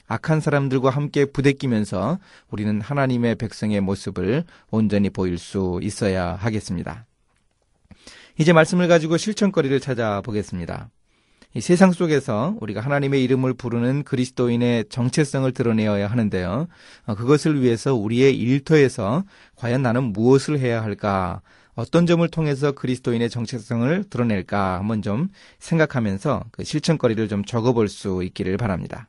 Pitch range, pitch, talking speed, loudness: 105-145 Hz, 120 Hz, 350 characters per minute, -21 LUFS